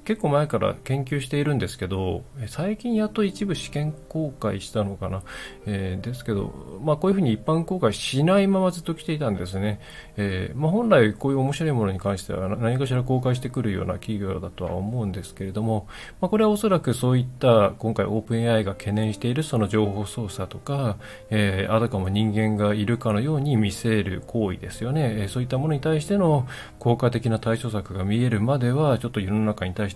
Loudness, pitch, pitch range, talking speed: -24 LUFS, 115 Hz, 105-145 Hz, 435 characters per minute